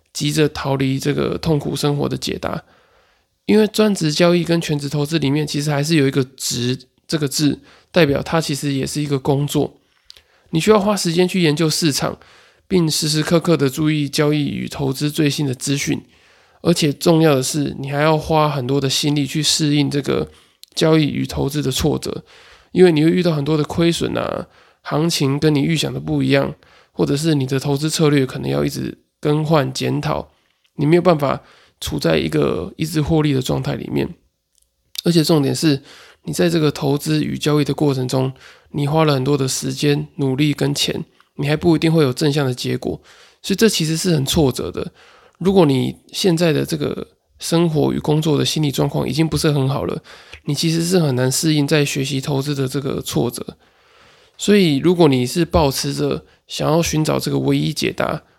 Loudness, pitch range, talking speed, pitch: -18 LUFS, 140-160 Hz, 285 characters per minute, 150 Hz